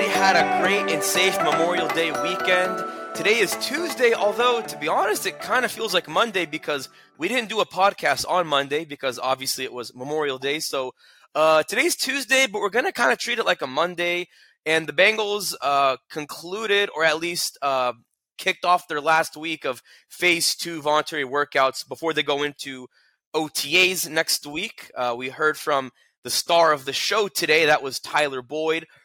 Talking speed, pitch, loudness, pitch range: 185 wpm, 160 Hz, -22 LUFS, 140-190 Hz